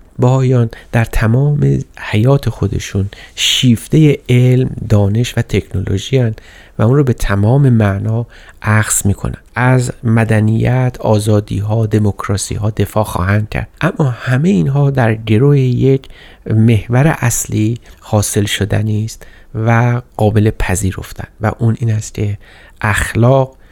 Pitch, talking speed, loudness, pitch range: 110 Hz, 115 wpm, -14 LUFS, 105-125 Hz